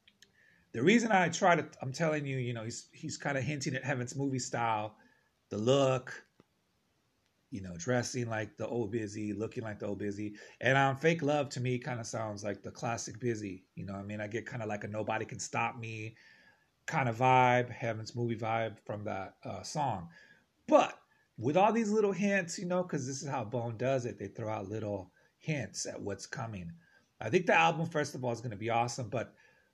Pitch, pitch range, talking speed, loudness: 120 Hz, 110-140 Hz, 215 wpm, -33 LUFS